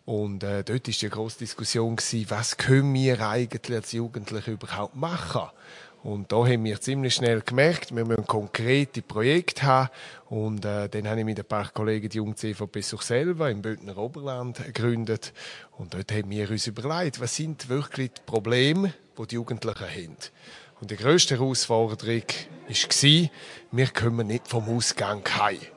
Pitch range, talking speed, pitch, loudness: 110-130 Hz, 165 wpm, 115 Hz, -26 LUFS